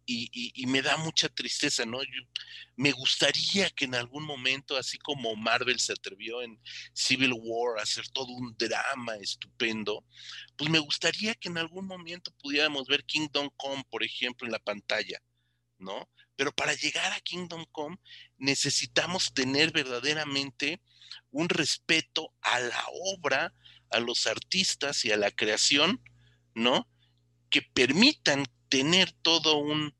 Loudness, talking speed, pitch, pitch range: -28 LUFS, 145 wpm, 140 Hz, 120-155 Hz